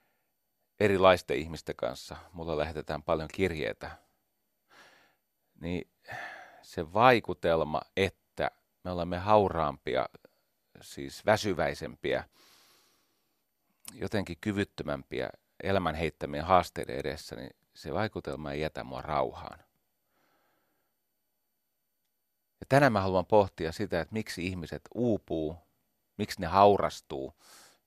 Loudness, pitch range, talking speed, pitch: -30 LUFS, 80-100 Hz, 90 wpm, 90 Hz